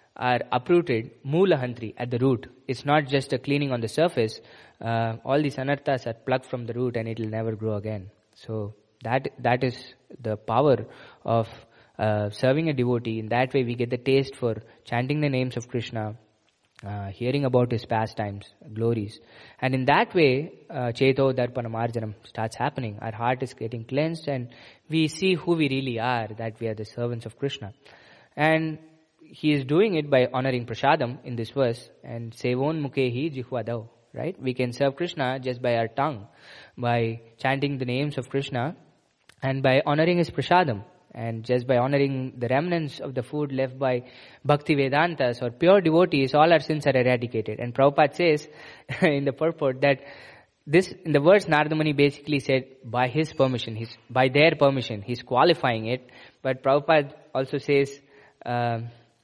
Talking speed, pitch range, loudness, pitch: 175 wpm, 115-145 Hz, -25 LUFS, 130 Hz